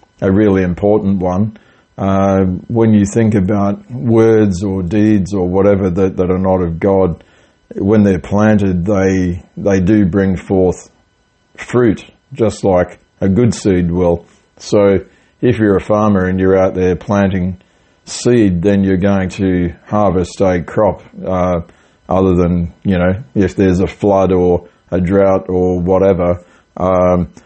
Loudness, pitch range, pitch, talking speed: -13 LUFS, 90-100 Hz, 95 Hz, 150 wpm